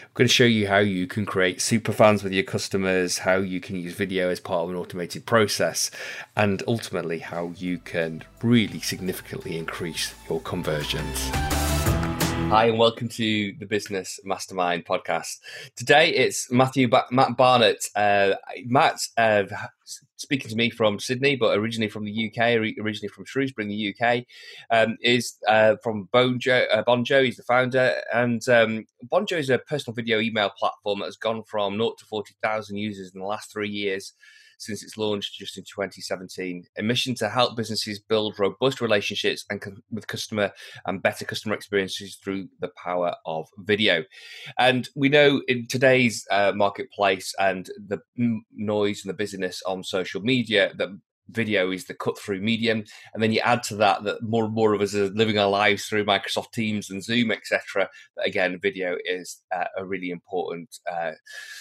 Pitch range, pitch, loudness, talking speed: 95-120 Hz, 105 Hz, -24 LUFS, 175 wpm